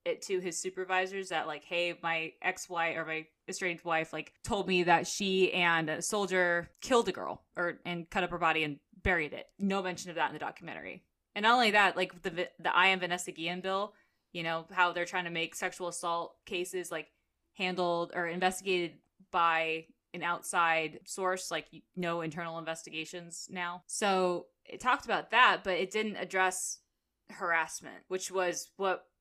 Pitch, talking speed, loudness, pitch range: 175 Hz, 185 wpm, -32 LUFS, 165-185 Hz